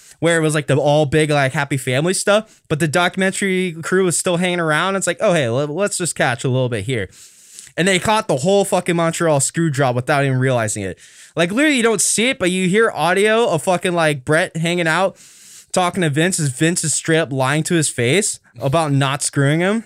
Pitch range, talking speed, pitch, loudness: 145-185 Hz, 225 wpm, 165 Hz, -17 LUFS